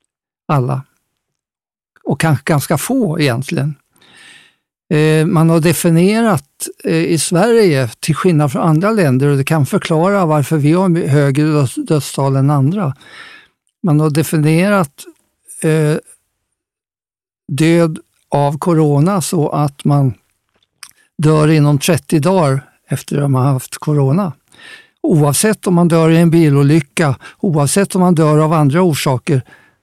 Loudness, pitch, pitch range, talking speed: -13 LUFS, 160 Hz, 145-180 Hz, 125 wpm